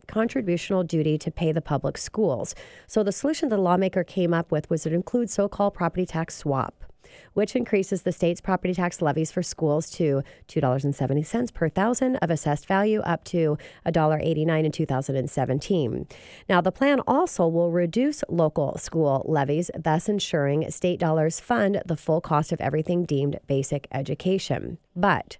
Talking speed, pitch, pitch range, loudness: 160 wpm, 170 Hz, 155-195 Hz, -25 LUFS